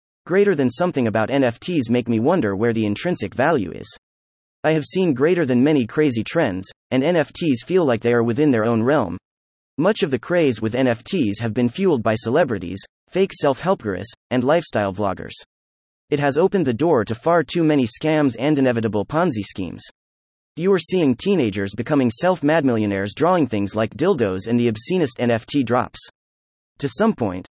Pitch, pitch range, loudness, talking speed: 120 Hz, 105-155 Hz, -20 LUFS, 175 wpm